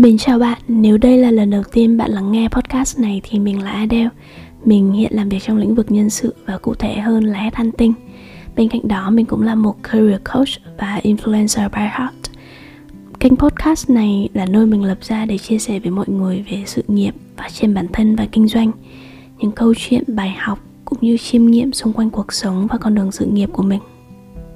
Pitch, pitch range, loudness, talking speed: 220 Hz, 200-230 Hz, -15 LUFS, 220 wpm